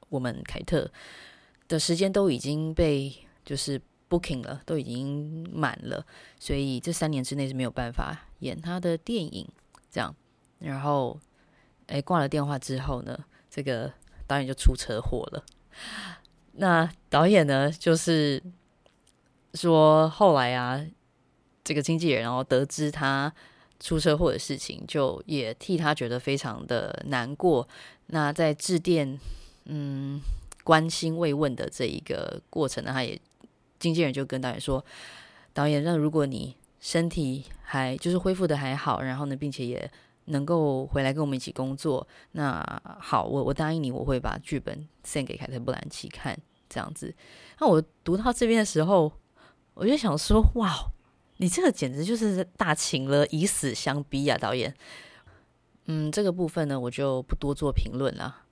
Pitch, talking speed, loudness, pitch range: 150 Hz, 235 characters per minute, -27 LUFS, 135-165 Hz